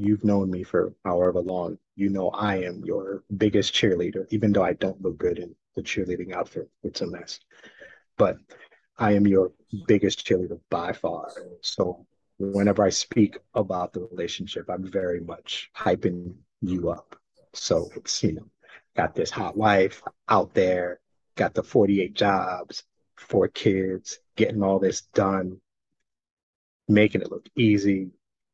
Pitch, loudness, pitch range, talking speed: 95 Hz, -25 LUFS, 90-100 Hz, 150 wpm